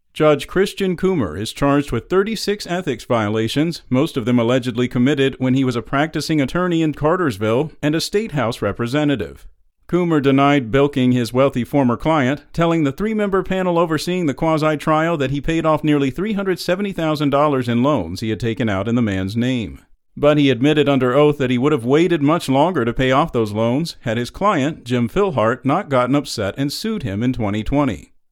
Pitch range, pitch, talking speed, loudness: 120-160 Hz, 140 Hz, 185 wpm, -18 LUFS